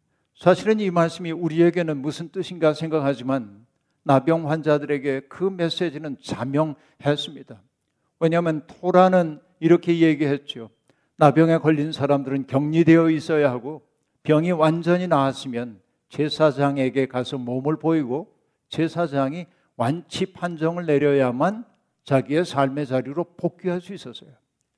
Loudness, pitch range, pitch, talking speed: -22 LUFS, 140-170 Hz, 155 Hz, 295 characters per minute